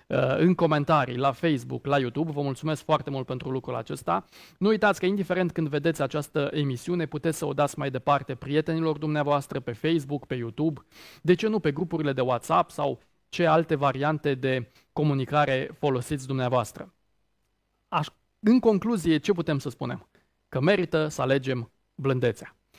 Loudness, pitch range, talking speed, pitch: -26 LUFS, 130-160 Hz, 160 wpm, 145 Hz